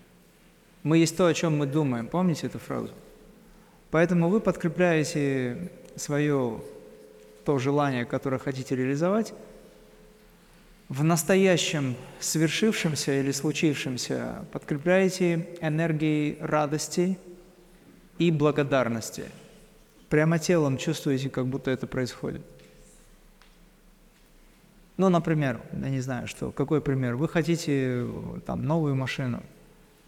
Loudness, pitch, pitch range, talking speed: -26 LUFS, 155 Hz, 135-175 Hz, 100 wpm